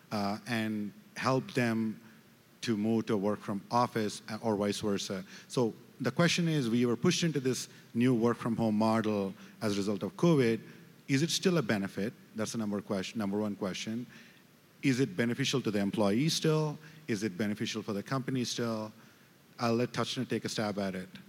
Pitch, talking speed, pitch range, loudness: 115 Hz, 180 wpm, 105-125 Hz, -32 LUFS